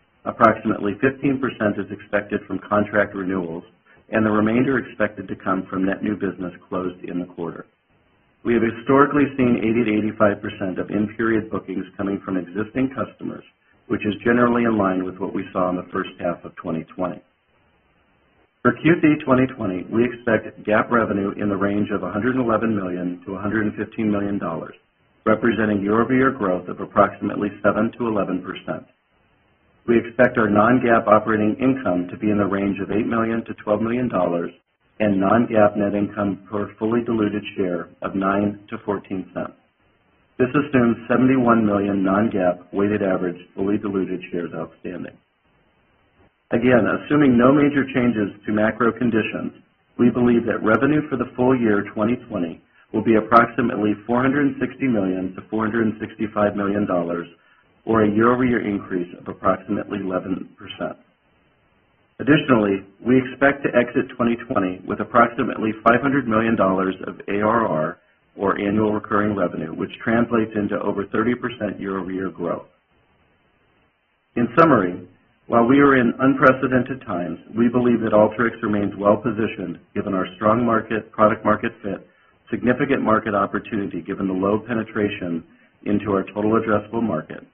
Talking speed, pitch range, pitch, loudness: 145 wpm, 100-120 Hz, 105 Hz, -21 LUFS